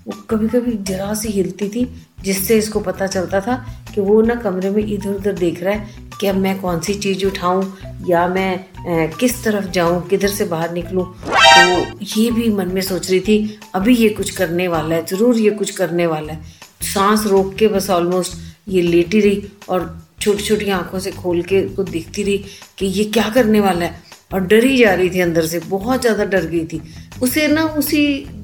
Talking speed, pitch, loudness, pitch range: 210 wpm, 195 Hz, -17 LUFS, 180-215 Hz